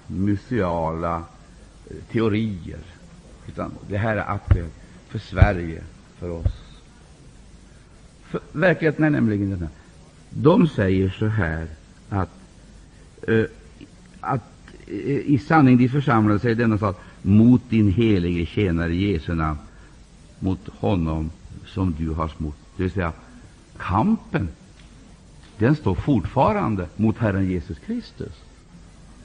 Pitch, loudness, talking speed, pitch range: 95 Hz, -22 LUFS, 105 wpm, 85-110 Hz